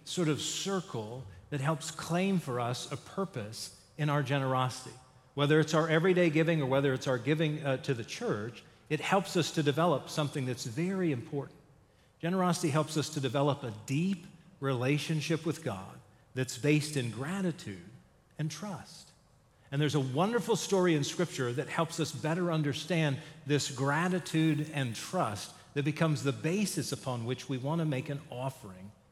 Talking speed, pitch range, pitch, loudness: 165 wpm, 130-165 Hz, 150 Hz, -32 LUFS